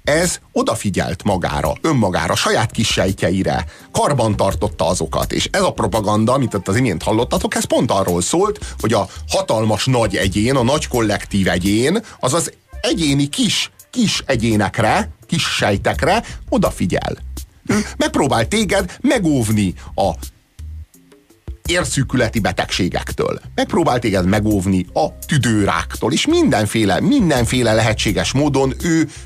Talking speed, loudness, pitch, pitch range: 115 wpm, -17 LUFS, 110 Hz, 95-135 Hz